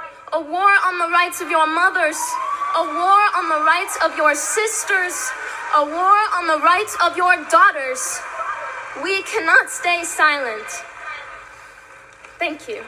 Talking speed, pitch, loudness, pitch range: 140 wpm, 345 Hz, -17 LUFS, 310-380 Hz